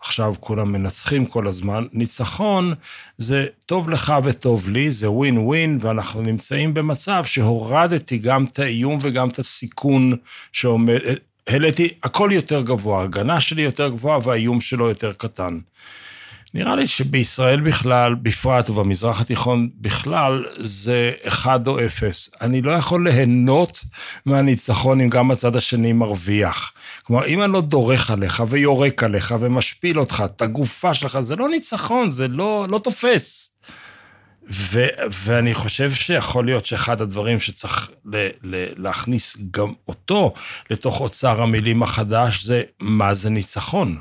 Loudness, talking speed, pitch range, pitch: -19 LUFS, 135 wpm, 110-140 Hz, 125 Hz